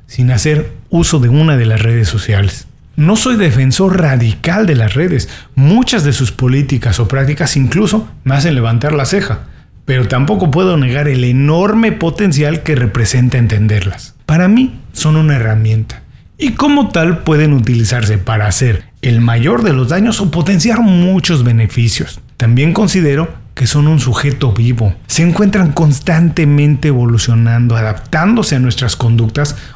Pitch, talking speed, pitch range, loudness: 135 Hz, 150 wpm, 115-165 Hz, -11 LUFS